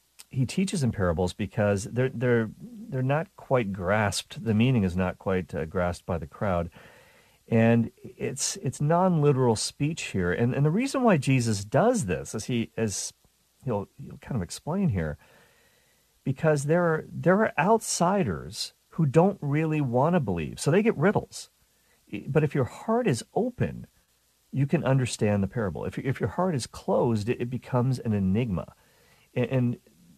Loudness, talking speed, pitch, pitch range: -27 LUFS, 165 wpm, 125 Hz, 105-155 Hz